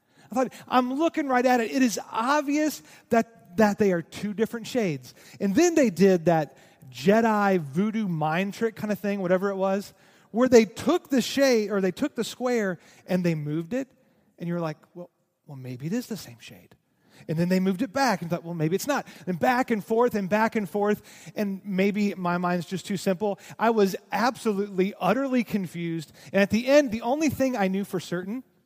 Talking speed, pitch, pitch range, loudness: 210 wpm, 200 Hz, 180-235 Hz, -25 LUFS